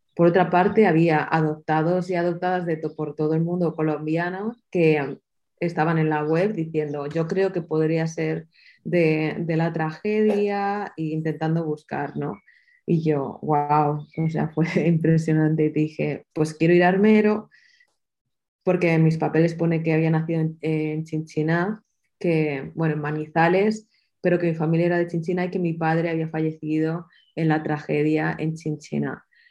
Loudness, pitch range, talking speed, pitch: -23 LUFS, 155-175 Hz, 165 wpm, 160 Hz